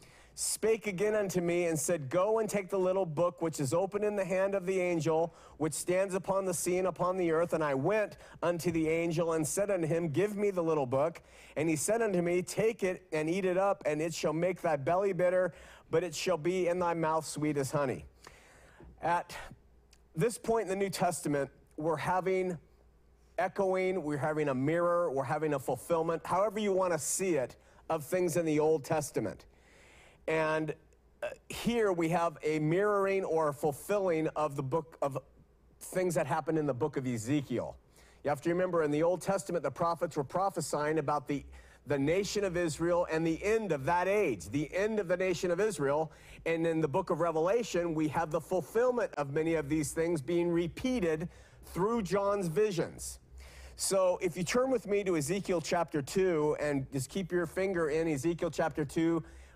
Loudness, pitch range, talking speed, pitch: -32 LUFS, 155-185 Hz, 195 wpm, 170 Hz